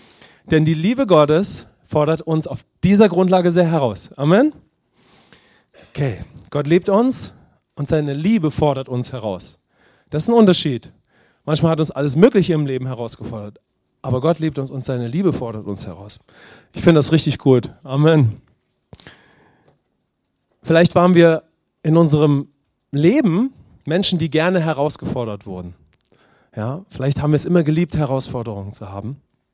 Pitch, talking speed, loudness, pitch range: 150 Hz, 145 wpm, -17 LUFS, 125-170 Hz